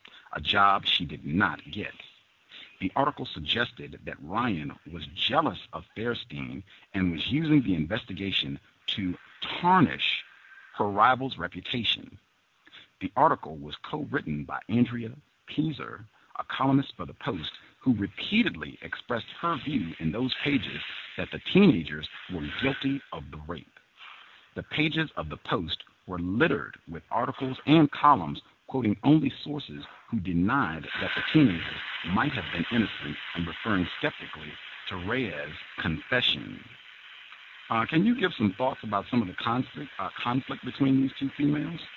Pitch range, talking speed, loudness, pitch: 90-140 Hz, 145 wpm, -28 LUFS, 120 Hz